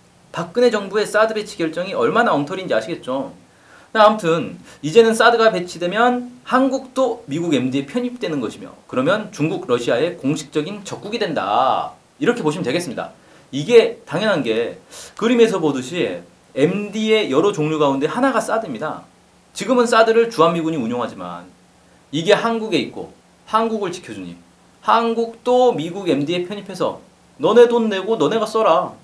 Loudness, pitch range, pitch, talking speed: -18 LUFS, 160-230 Hz, 210 Hz, 340 characters per minute